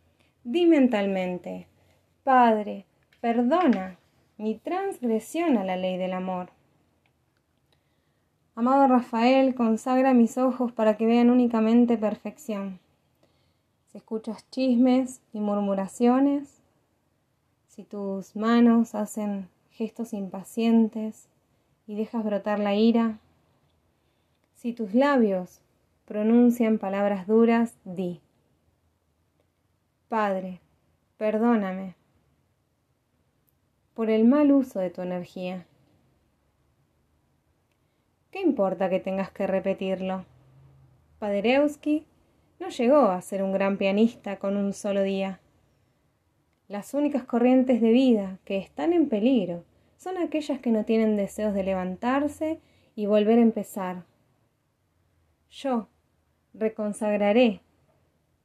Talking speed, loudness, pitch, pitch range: 95 wpm, -25 LUFS, 210 Hz, 190-240 Hz